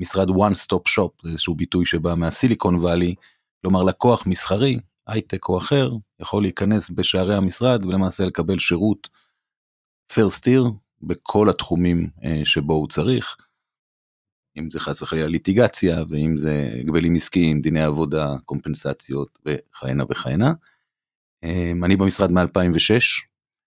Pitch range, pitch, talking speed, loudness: 80-100 Hz, 90 Hz, 115 wpm, -20 LUFS